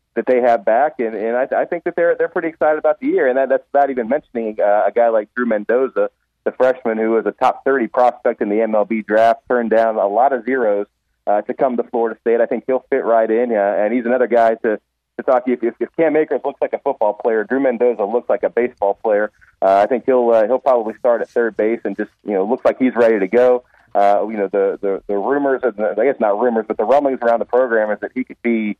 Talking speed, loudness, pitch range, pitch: 265 wpm, -17 LUFS, 110-130 Hz, 120 Hz